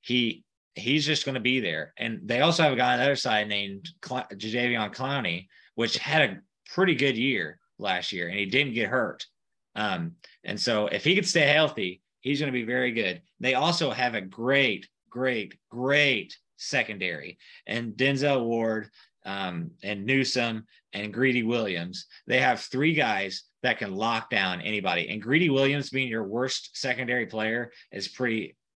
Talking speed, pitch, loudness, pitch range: 175 wpm, 125 Hz, -26 LUFS, 110-140 Hz